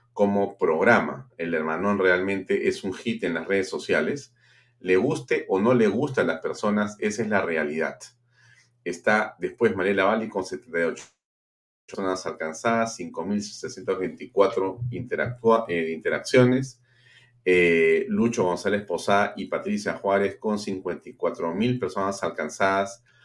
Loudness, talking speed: -25 LUFS, 120 wpm